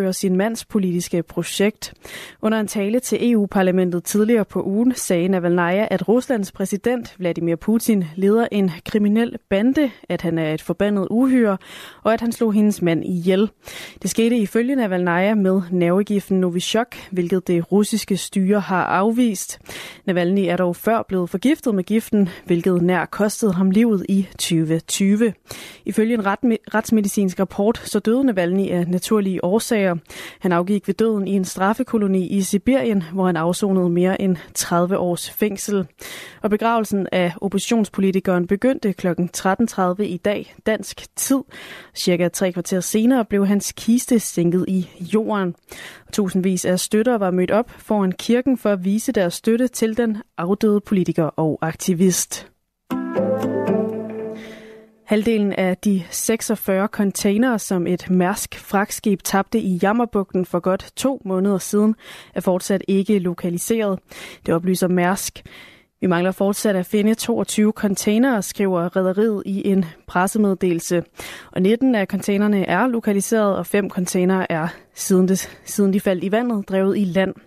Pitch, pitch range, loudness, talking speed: 195 Hz, 185-220 Hz, -20 LUFS, 145 wpm